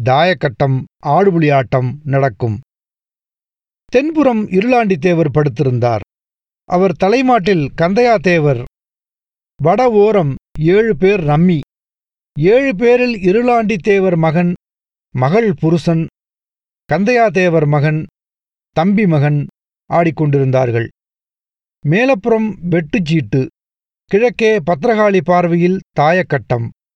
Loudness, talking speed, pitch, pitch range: -14 LUFS, 70 wpm, 175 Hz, 145-210 Hz